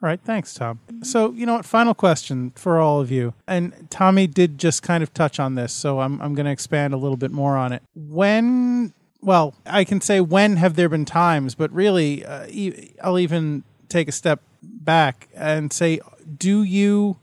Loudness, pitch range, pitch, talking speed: -20 LUFS, 145-190 Hz, 165 Hz, 195 wpm